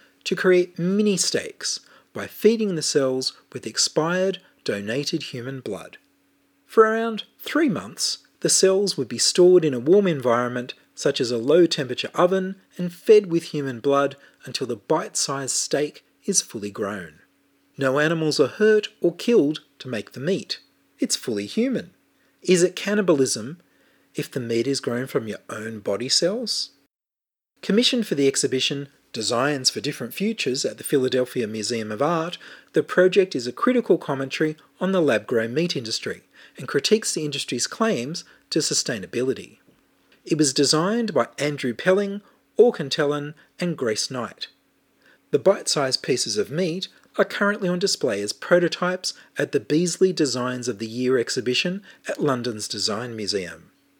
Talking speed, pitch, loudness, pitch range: 150 wpm, 155 Hz, -22 LUFS, 130-190 Hz